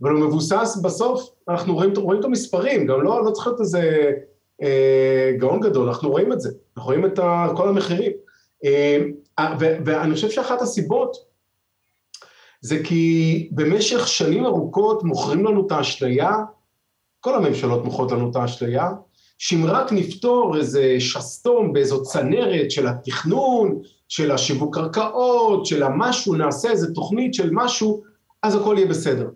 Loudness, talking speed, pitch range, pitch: -20 LUFS, 145 wpm, 145-220 Hz, 175 Hz